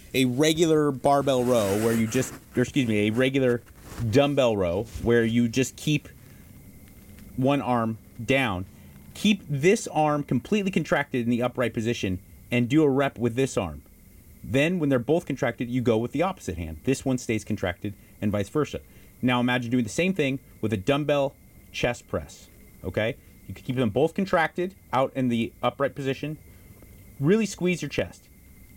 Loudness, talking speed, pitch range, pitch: -25 LUFS, 170 wpm, 105-140 Hz, 125 Hz